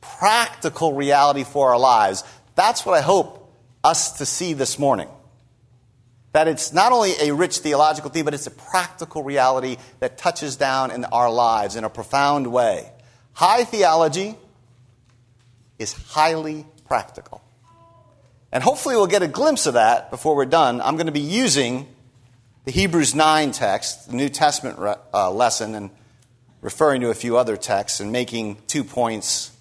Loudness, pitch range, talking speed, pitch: -20 LUFS, 120-155 Hz, 160 wpm, 130 Hz